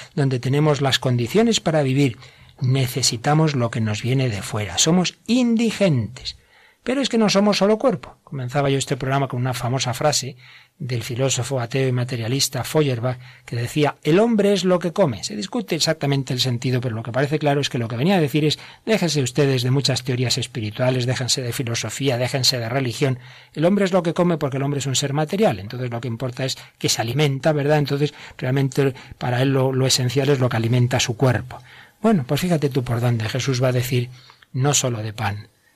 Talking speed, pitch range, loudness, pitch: 210 wpm, 125-150 Hz, -20 LUFS, 135 Hz